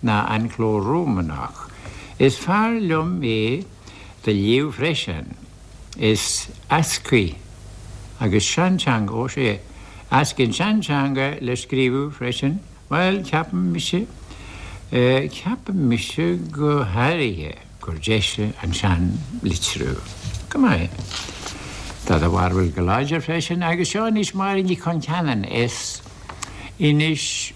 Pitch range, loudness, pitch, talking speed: 100-160 Hz, -21 LUFS, 125 Hz, 110 wpm